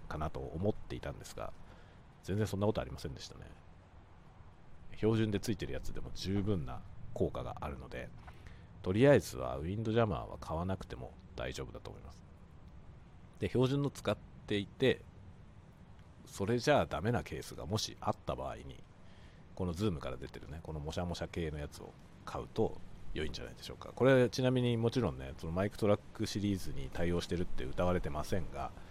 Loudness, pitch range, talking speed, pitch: -36 LUFS, 80-105 Hz, 390 characters per minute, 90 Hz